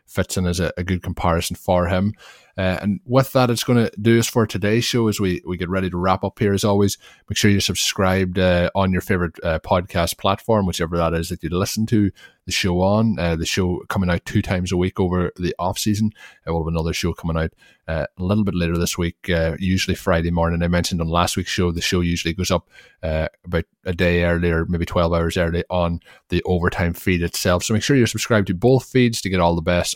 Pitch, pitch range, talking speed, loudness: 90 Hz, 85-100 Hz, 240 wpm, -20 LUFS